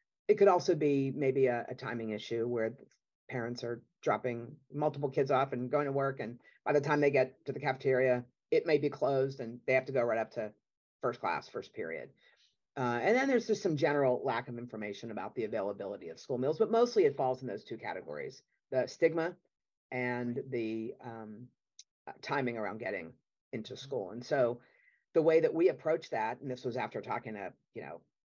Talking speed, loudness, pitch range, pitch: 200 wpm, -33 LUFS, 120-155 Hz, 130 Hz